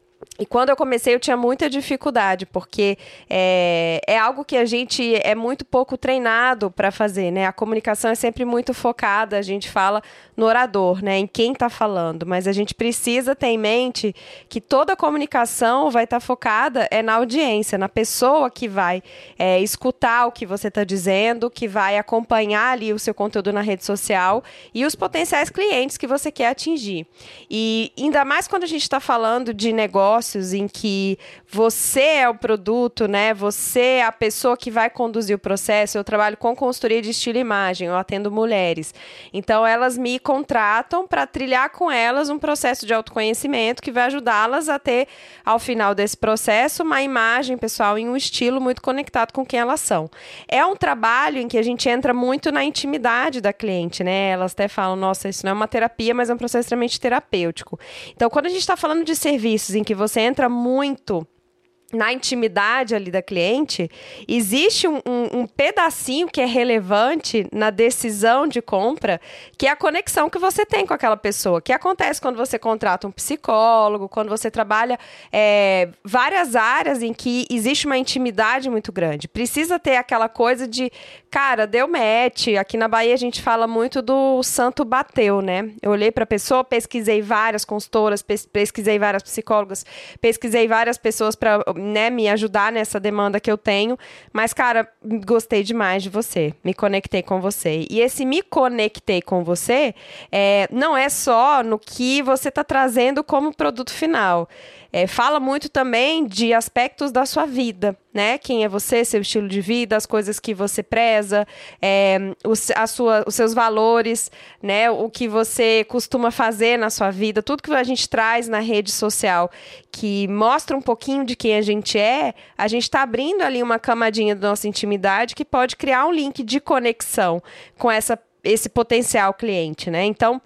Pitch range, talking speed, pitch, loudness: 210-255 Hz, 180 wpm, 230 Hz, -19 LUFS